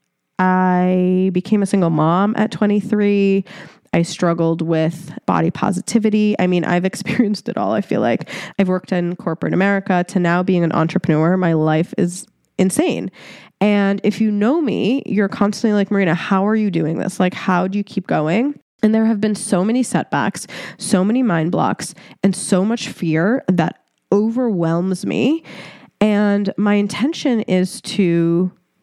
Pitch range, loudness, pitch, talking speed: 180-215 Hz, -18 LUFS, 195 Hz, 160 wpm